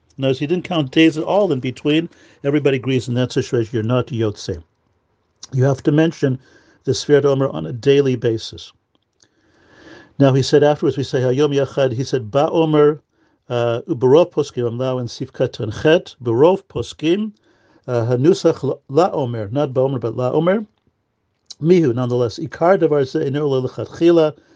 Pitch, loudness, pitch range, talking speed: 135 Hz, -18 LUFS, 120-155 Hz, 150 wpm